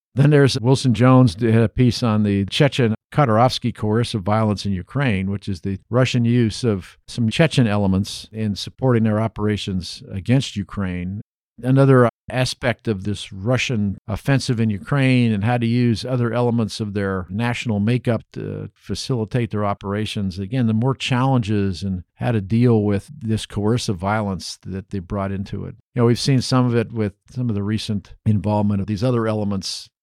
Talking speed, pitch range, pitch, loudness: 170 wpm, 100-125 Hz, 110 Hz, -20 LUFS